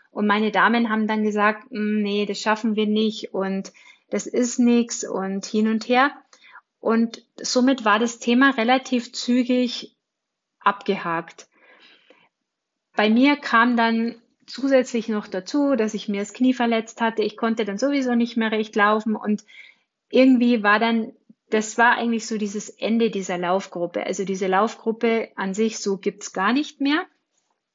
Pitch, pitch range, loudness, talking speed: 225 Hz, 210-245 Hz, -22 LUFS, 155 wpm